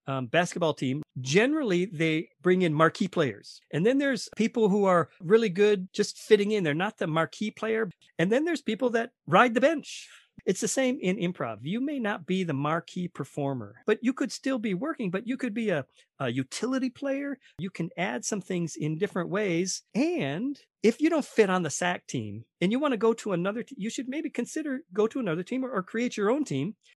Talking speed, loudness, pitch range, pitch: 220 wpm, -28 LUFS, 175-250 Hz, 210 Hz